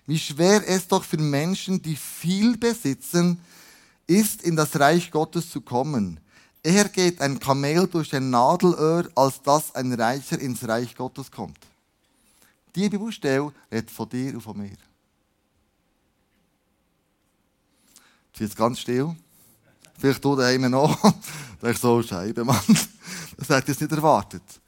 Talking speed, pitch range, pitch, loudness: 140 wpm, 120-175 Hz, 145 Hz, -23 LUFS